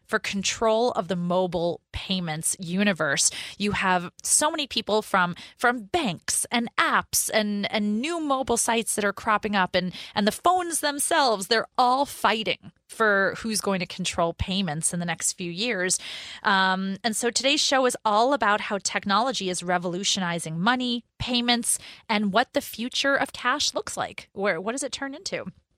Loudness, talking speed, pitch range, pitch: -24 LUFS, 170 wpm, 185-245 Hz, 210 Hz